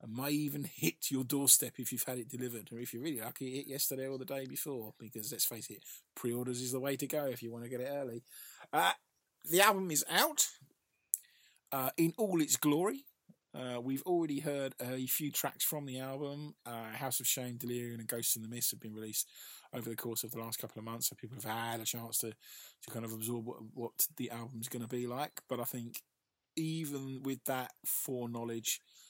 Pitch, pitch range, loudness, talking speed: 125 Hz, 115-135 Hz, -36 LUFS, 225 wpm